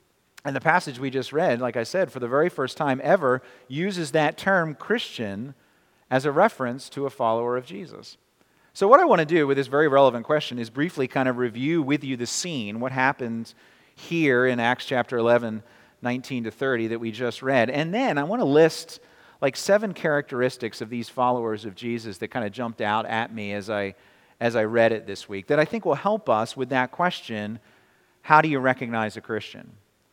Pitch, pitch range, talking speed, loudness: 125 Hz, 115-145 Hz, 210 wpm, -24 LUFS